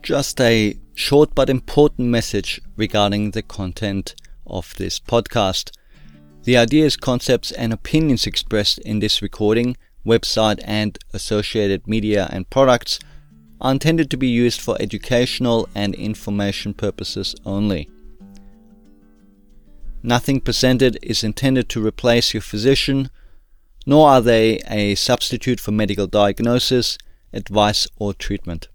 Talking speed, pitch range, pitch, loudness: 120 wpm, 100-120 Hz, 105 Hz, -18 LUFS